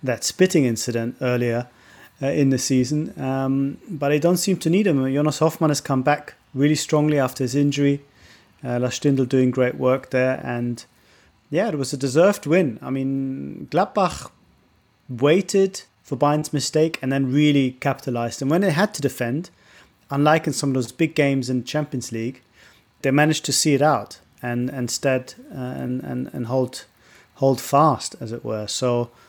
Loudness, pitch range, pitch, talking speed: -21 LUFS, 125-150 Hz, 135 Hz, 175 wpm